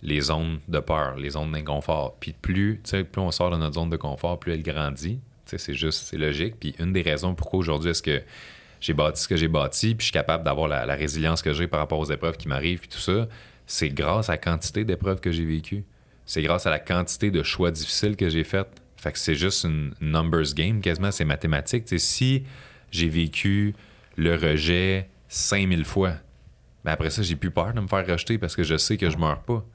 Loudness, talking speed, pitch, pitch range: -25 LUFS, 230 wpm, 85 Hz, 75-95 Hz